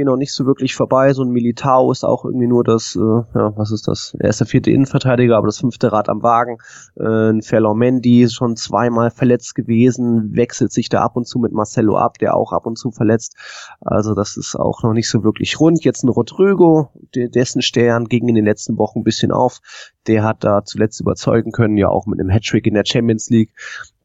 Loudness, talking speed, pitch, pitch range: -16 LUFS, 220 wpm, 115 Hz, 110-125 Hz